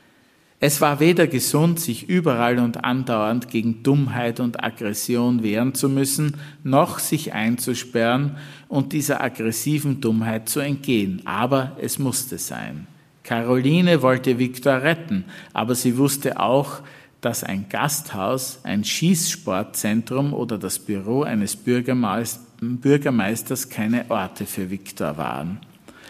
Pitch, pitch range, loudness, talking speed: 130 Hz, 115-145 Hz, -22 LUFS, 120 wpm